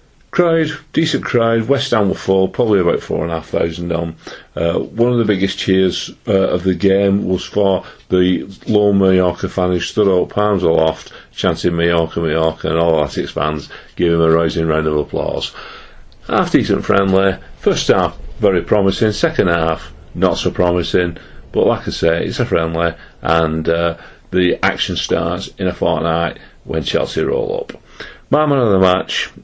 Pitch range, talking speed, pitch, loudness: 85-100 Hz, 165 wpm, 90 Hz, -16 LUFS